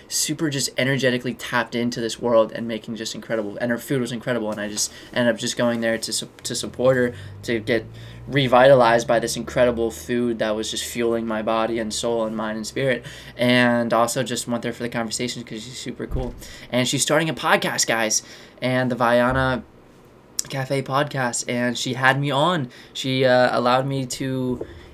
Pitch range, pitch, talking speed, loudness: 115-130 Hz, 120 Hz, 195 wpm, -22 LUFS